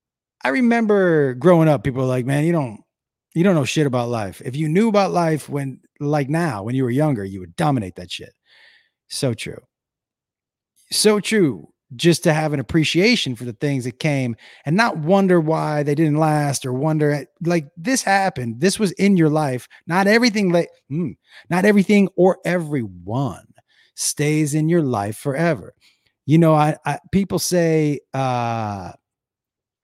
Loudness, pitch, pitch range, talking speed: -19 LUFS, 155 Hz, 130-175 Hz, 170 wpm